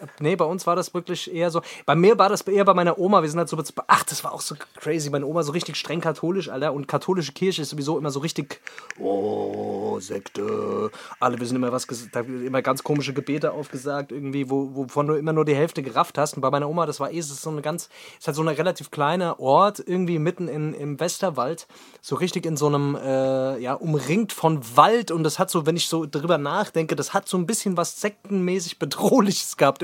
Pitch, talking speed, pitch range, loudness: 160 Hz, 235 wpm, 145-175 Hz, -23 LUFS